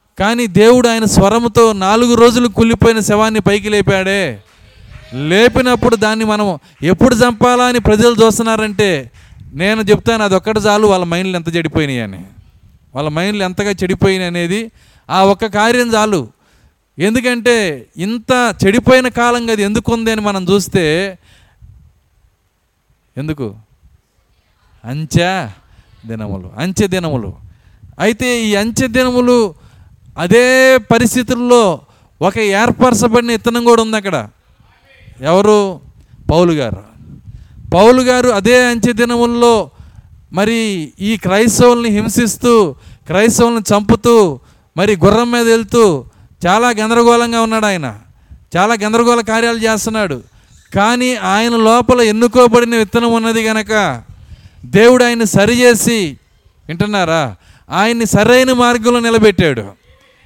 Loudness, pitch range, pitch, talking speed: -12 LUFS, 140-235 Hz, 205 Hz, 105 wpm